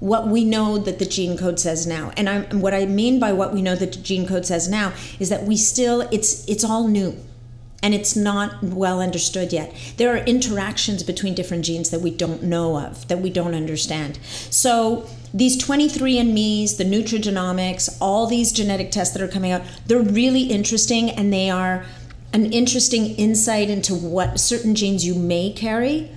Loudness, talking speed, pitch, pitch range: -20 LUFS, 185 wpm, 195 Hz, 180-220 Hz